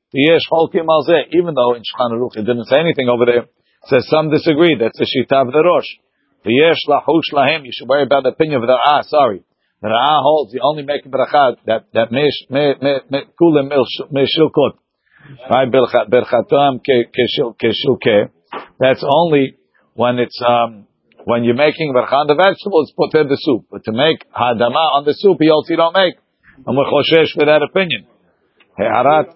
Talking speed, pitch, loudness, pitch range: 175 wpm, 140 Hz, -14 LUFS, 120-155 Hz